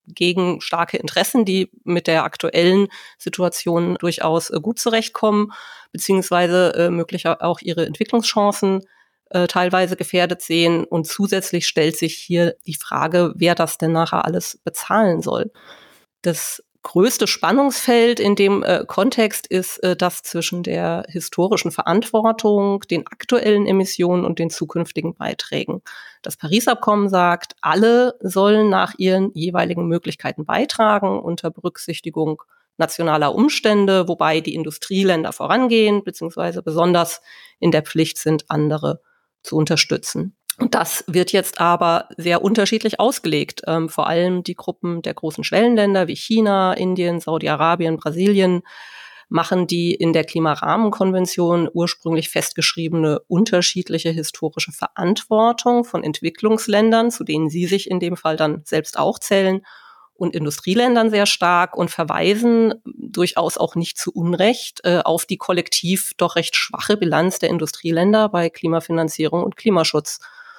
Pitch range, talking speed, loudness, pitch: 165-205 Hz, 125 wpm, -18 LUFS, 180 Hz